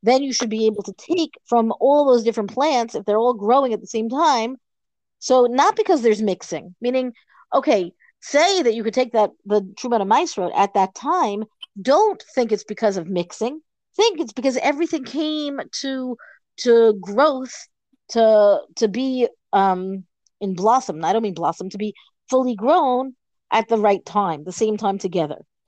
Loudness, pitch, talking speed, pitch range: -20 LUFS, 230 Hz, 180 wpm, 205-270 Hz